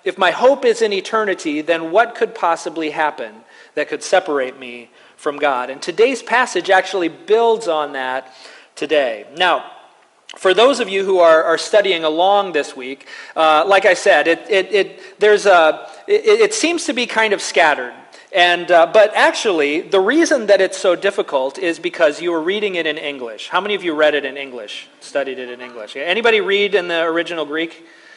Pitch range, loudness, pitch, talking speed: 155-220 Hz, -16 LUFS, 180 Hz, 195 wpm